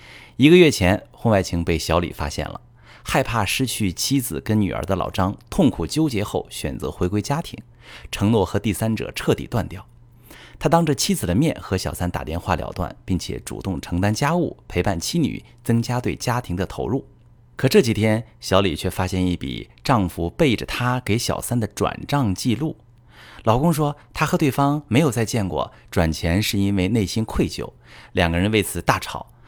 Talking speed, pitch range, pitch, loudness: 270 characters per minute, 95-125 Hz, 110 Hz, -21 LUFS